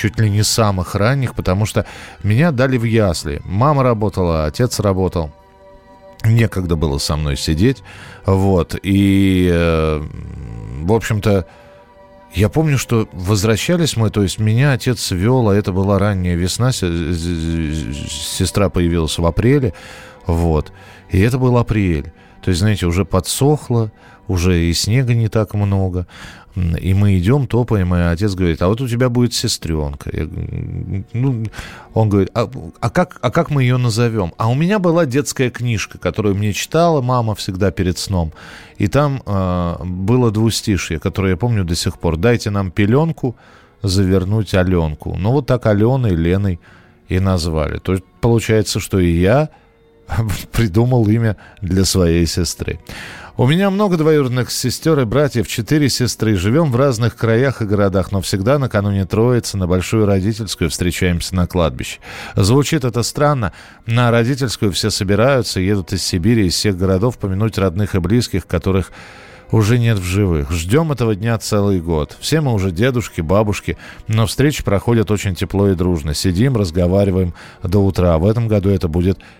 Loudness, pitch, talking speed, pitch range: -16 LUFS, 100 Hz, 155 wpm, 90-120 Hz